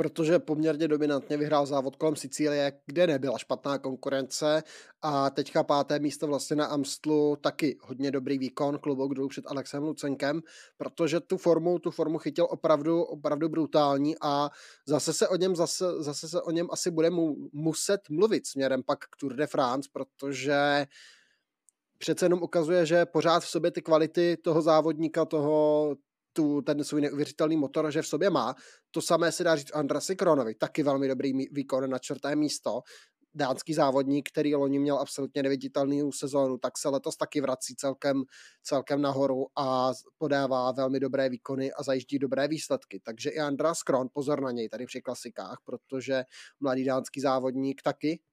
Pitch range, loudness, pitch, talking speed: 135-160 Hz, -29 LUFS, 145 Hz, 165 wpm